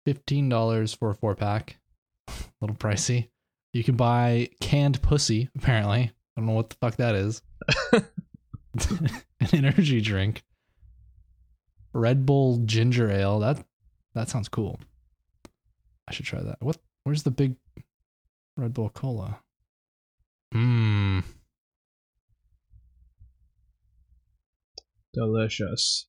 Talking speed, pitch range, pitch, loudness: 110 wpm, 100-125 Hz, 110 Hz, -26 LUFS